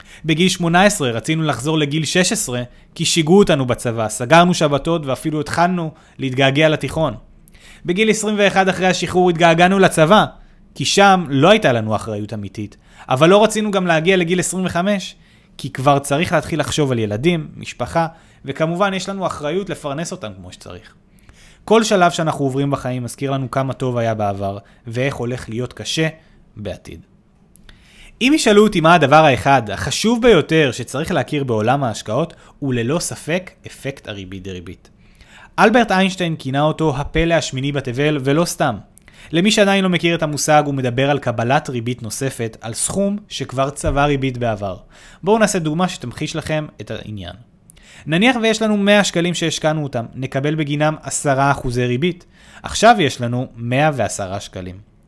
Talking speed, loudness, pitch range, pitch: 150 wpm, -17 LUFS, 125-175 Hz, 150 Hz